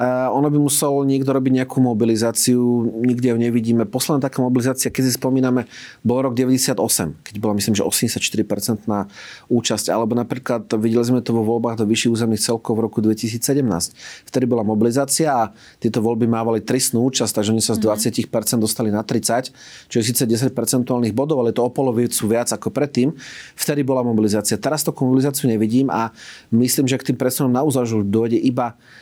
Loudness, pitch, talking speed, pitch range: -19 LUFS, 120 Hz, 180 wpm, 115-130 Hz